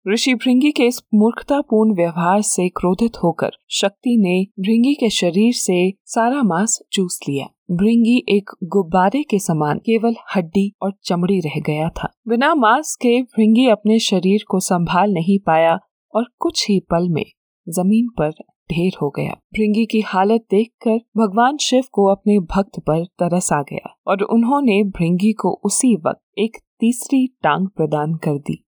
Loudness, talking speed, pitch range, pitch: -17 LUFS, 160 wpm, 180-230 Hz, 205 Hz